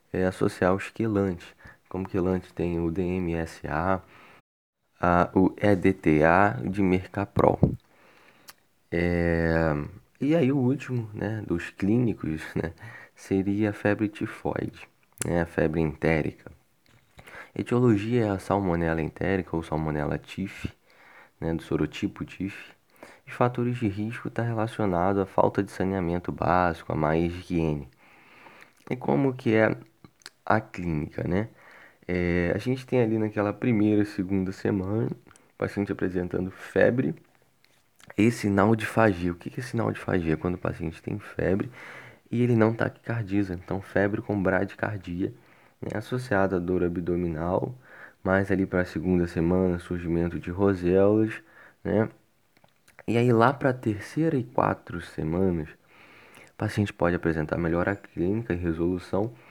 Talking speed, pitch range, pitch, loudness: 135 wpm, 85-110 Hz, 95 Hz, -27 LUFS